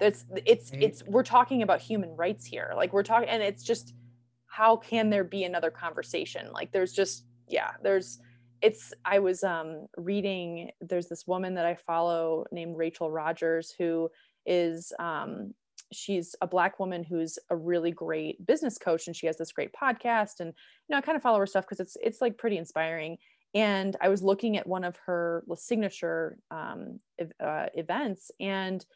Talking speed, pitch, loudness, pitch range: 180 wpm, 185 Hz, -29 LUFS, 165-215 Hz